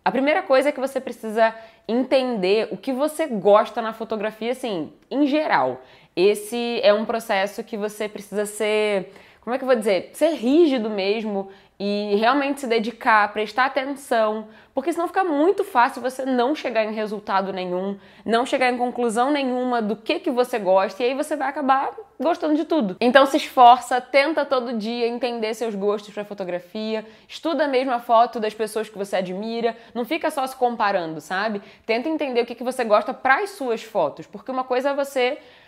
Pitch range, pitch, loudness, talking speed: 215-265 Hz, 235 Hz, -22 LUFS, 190 wpm